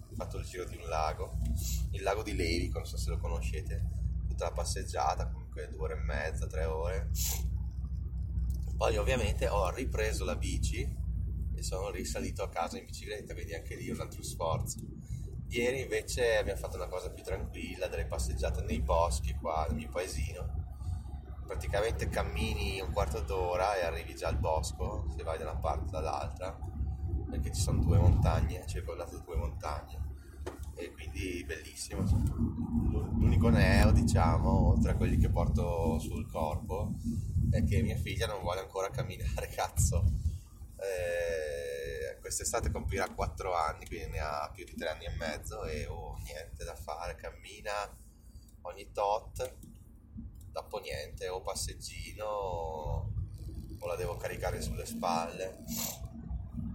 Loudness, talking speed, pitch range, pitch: -34 LUFS, 150 wpm, 80-100 Hz, 85 Hz